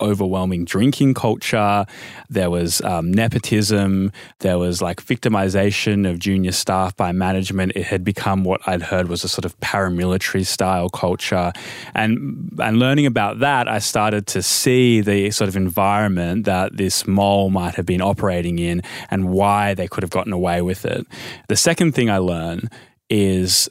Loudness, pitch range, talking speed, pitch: -19 LUFS, 95-105 Hz, 165 wpm, 95 Hz